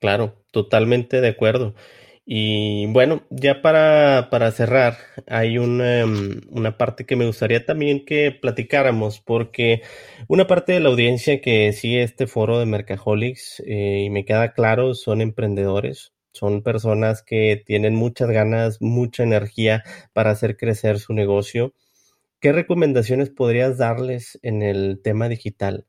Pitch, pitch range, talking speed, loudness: 115 Hz, 105-125 Hz, 140 wpm, -19 LUFS